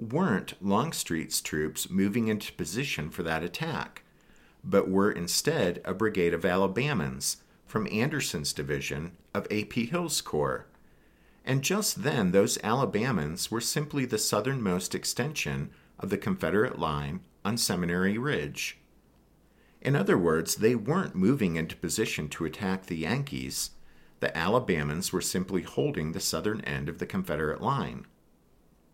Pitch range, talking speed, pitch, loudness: 80-115 Hz, 135 wpm, 95 Hz, -29 LUFS